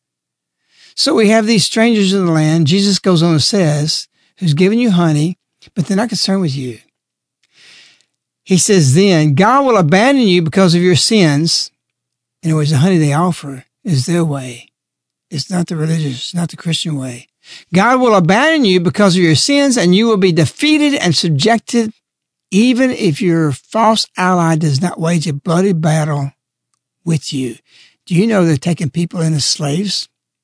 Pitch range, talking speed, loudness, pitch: 155-205 Hz, 175 wpm, -13 LUFS, 175 Hz